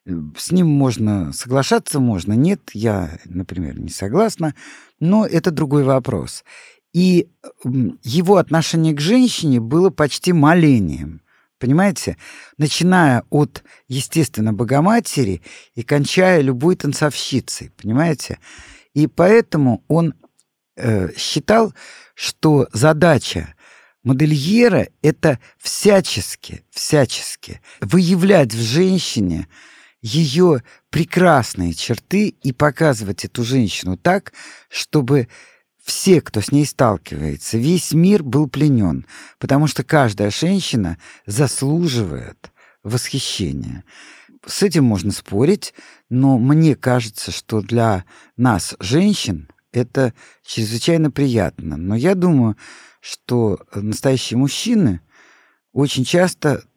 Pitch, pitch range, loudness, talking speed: 140 Hz, 115-165 Hz, -17 LUFS, 95 wpm